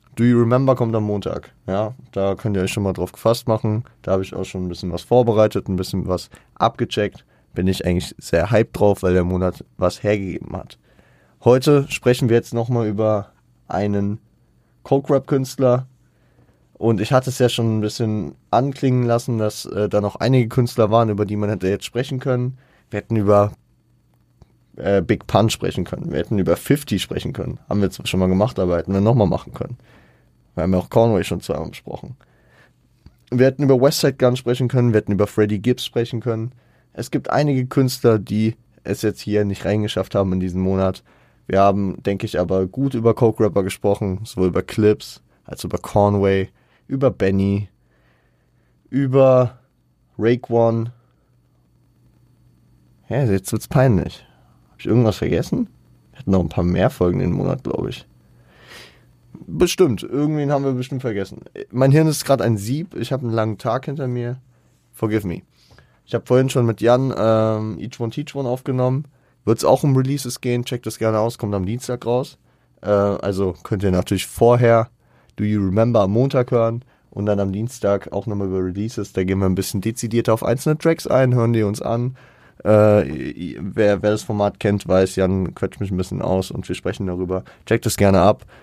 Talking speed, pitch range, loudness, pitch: 190 wpm, 95-125 Hz, -19 LUFS, 110 Hz